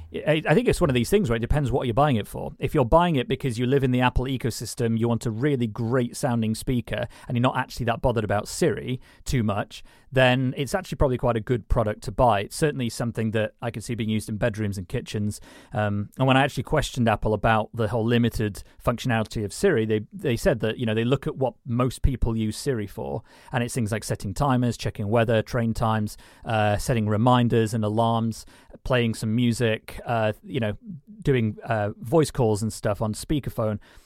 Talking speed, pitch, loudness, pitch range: 220 wpm, 120 Hz, -25 LUFS, 110-130 Hz